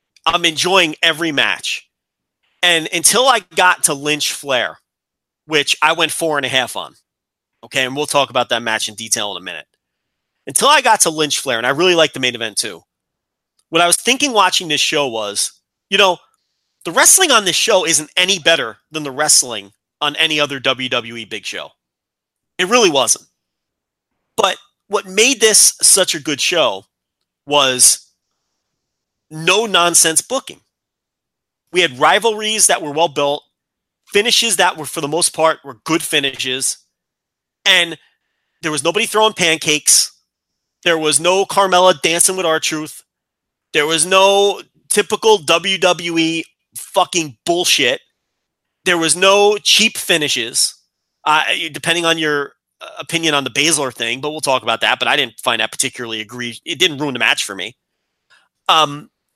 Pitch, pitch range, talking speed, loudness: 160 Hz, 140-180 Hz, 160 wpm, -14 LUFS